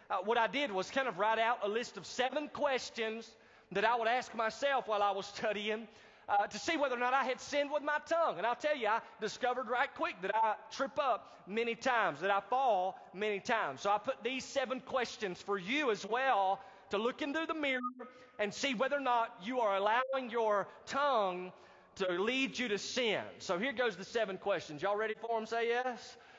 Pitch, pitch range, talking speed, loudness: 230 Hz, 210-260 Hz, 220 wpm, -35 LUFS